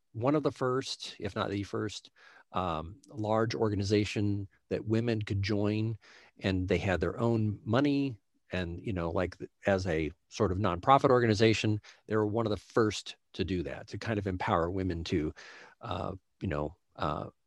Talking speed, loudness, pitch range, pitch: 170 wpm, -32 LUFS, 95-115 Hz, 105 Hz